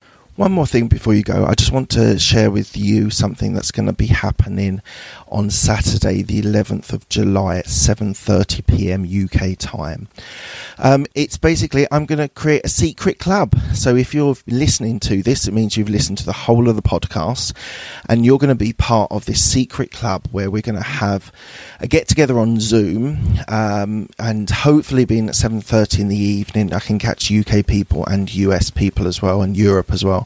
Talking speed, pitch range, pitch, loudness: 190 wpm, 100-115 Hz, 105 Hz, -16 LUFS